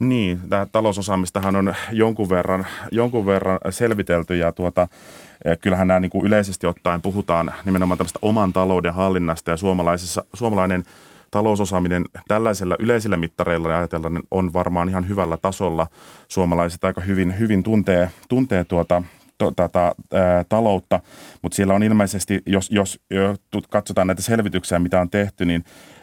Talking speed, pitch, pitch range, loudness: 140 wpm, 95 Hz, 90-100 Hz, -20 LUFS